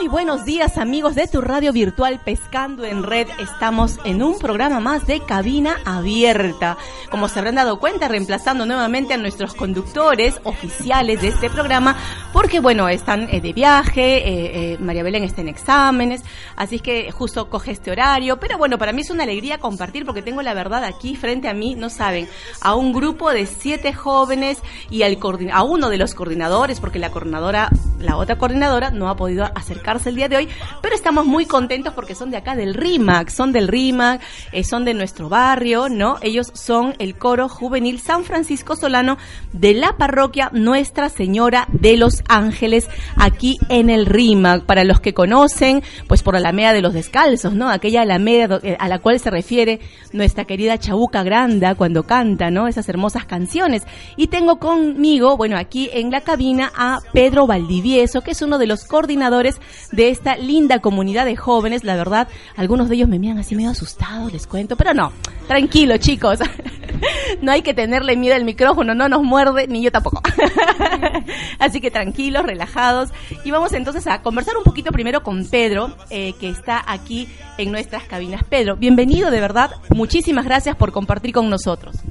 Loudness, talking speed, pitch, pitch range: -17 LUFS, 180 wpm, 240 Hz, 205-270 Hz